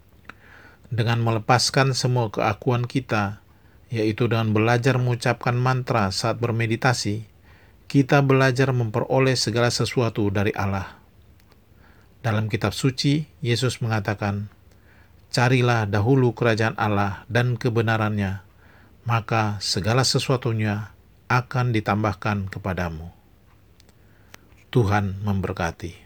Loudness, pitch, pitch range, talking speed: -22 LUFS, 110 Hz, 100-120 Hz, 90 wpm